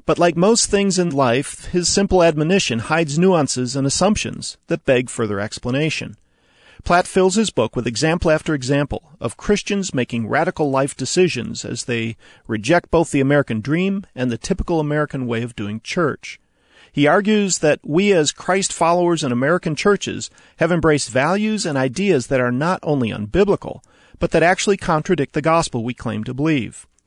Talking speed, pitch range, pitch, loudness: 170 wpm, 125-180 Hz, 155 Hz, -18 LUFS